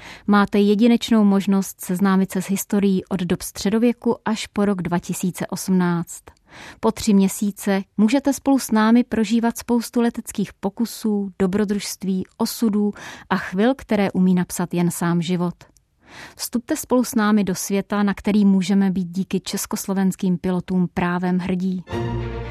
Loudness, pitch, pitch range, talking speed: -21 LUFS, 195 Hz, 185-215 Hz, 135 wpm